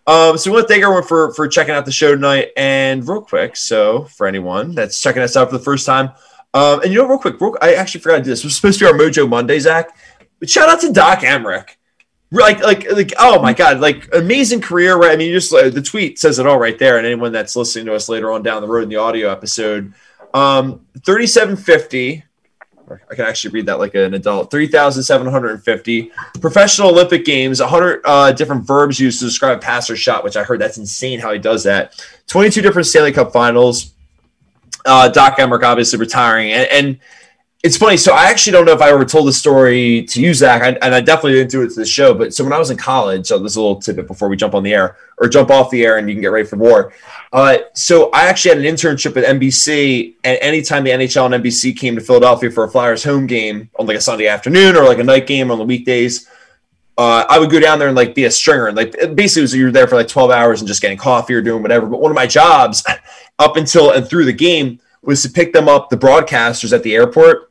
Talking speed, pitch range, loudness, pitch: 250 wpm, 120-165 Hz, -11 LUFS, 135 Hz